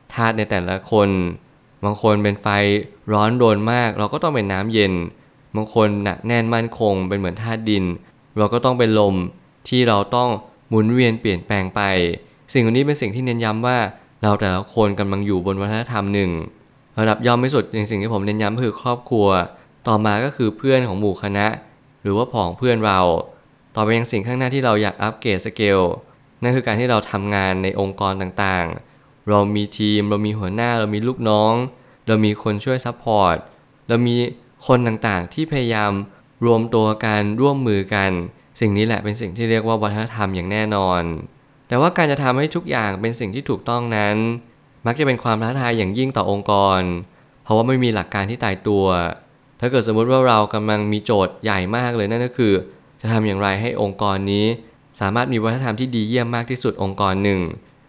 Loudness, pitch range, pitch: -19 LUFS, 100-120 Hz, 110 Hz